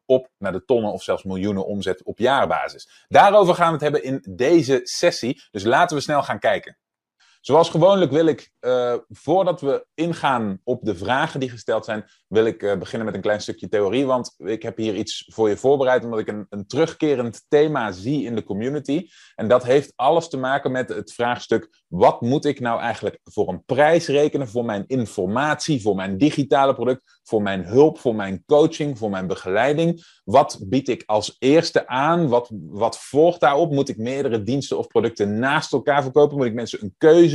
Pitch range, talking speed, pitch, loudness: 110-150 Hz, 200 wpm, 130 Hz, -20 LUFS